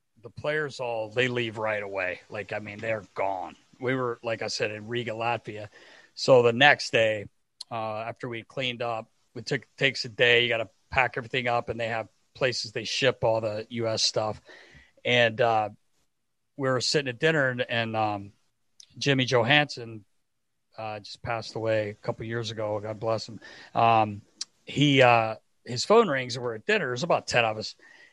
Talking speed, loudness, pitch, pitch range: 190 wpm, -26 LUFS, 115 Hz, 110-125 Hz